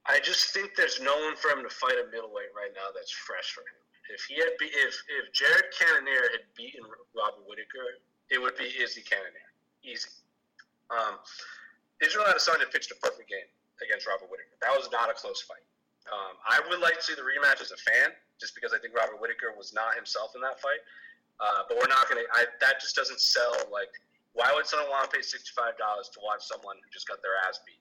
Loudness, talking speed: -28 LUFS, 220 wpm